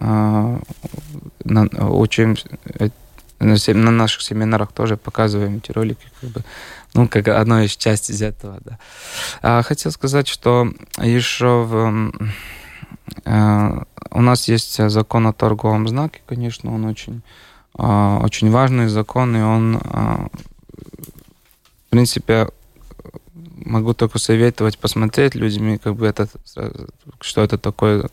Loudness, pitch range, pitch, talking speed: -17 LUFS, 105-120 Hz, 110 Hz, 125 wpm